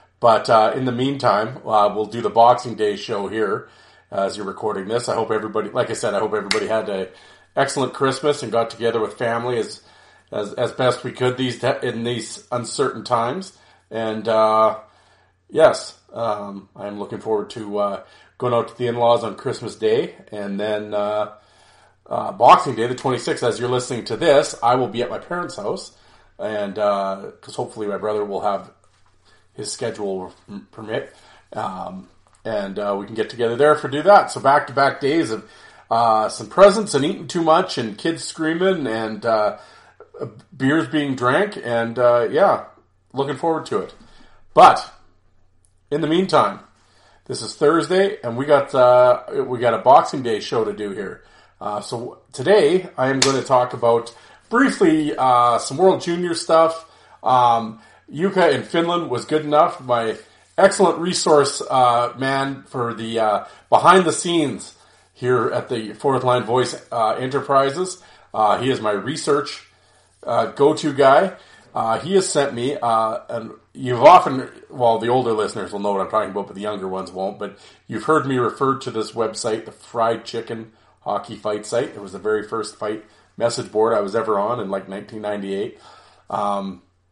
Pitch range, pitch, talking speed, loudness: 105-140 Hz, 120 Hz, 175 wpm, -19 LUFS